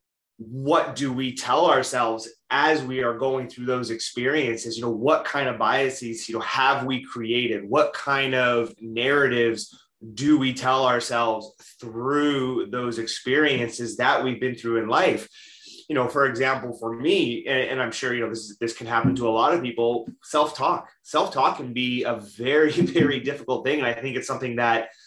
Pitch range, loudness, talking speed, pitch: 115-130 Hz, -23 LUFS, 185 wpm, 120 Hz